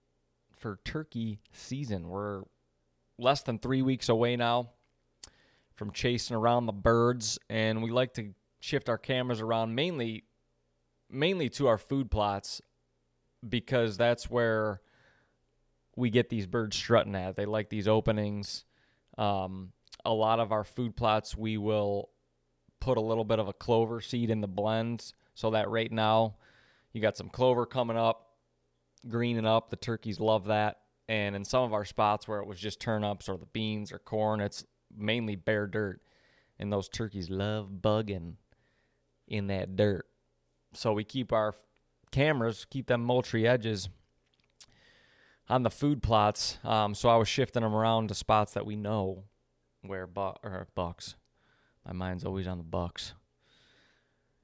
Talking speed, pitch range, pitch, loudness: 155 wpm, 95-115 Hz, 110 Hz, -31 LUFS